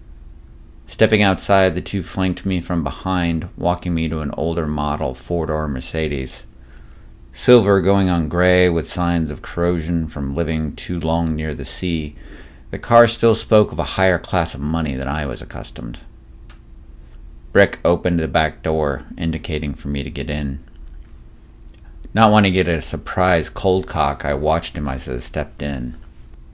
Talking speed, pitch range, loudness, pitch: 165 wpm, 70-90 Hz, -19 LUFS, 80 Hz